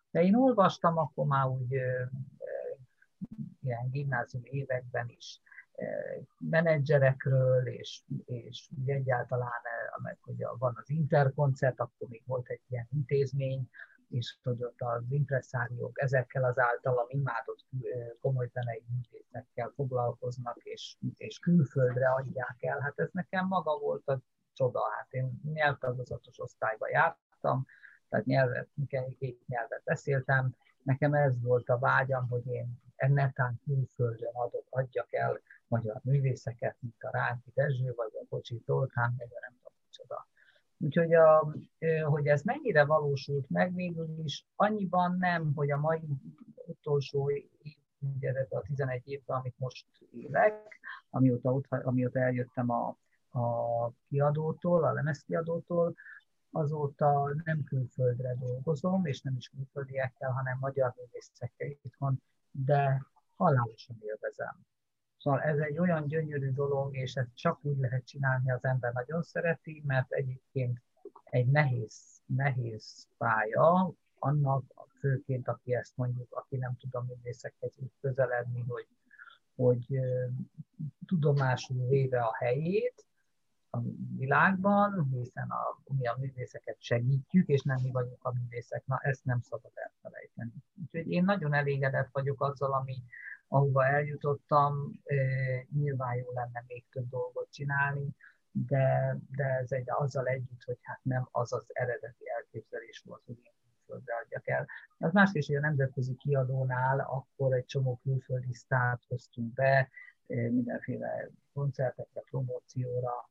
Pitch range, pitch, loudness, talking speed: 125-145 Hz, 135 Hz, -32 LUFS, 130 wpm